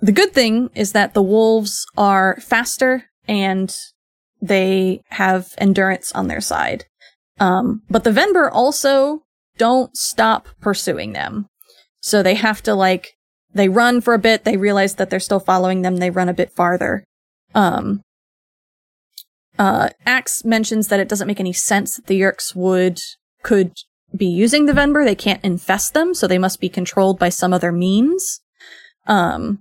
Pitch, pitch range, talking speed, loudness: 205 Hz, 190-235 Hz, 160 wpm, -17 LUFS